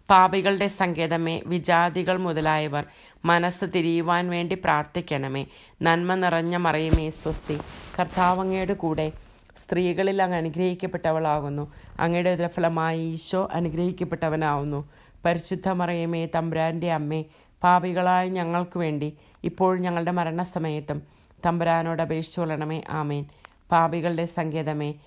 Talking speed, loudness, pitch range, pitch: 85 wpm, -25 LUFS, 155-180 Hz, 170 Hz